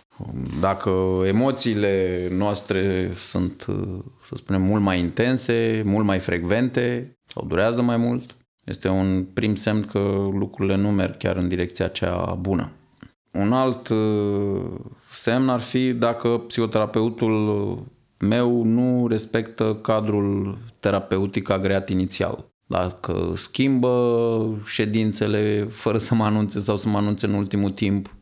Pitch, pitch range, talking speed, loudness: 105 Hz, 95-115 Hz, 120 wpm, -23 LUFS